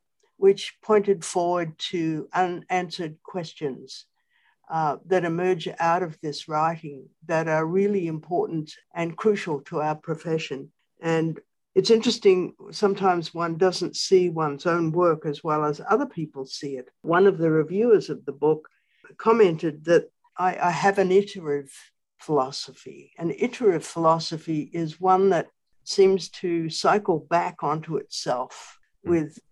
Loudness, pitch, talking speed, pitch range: -24 LUFS, 170 Hz, 135 wpm, 155-190 Hz